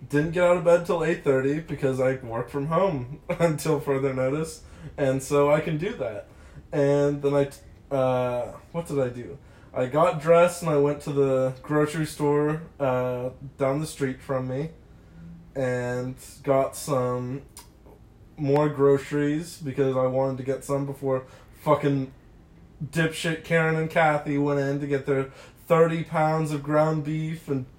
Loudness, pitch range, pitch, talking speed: -25 LUFS, 130-155 Hz, 140 Hz, 160 wpm